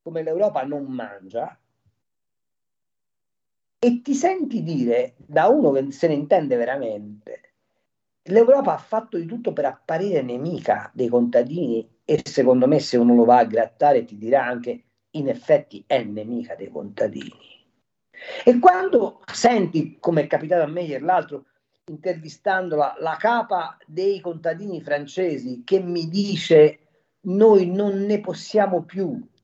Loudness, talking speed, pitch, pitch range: -21 LUFS, 135 wpm, 165 Hz, 135-200 Hz